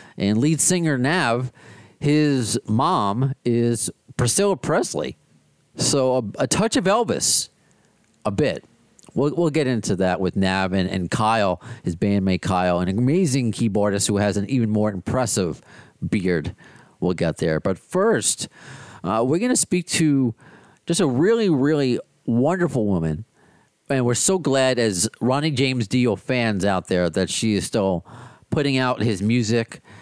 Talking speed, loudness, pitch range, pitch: 150 wpm, -21 LUFS, 100-140 Hz, 120 Hz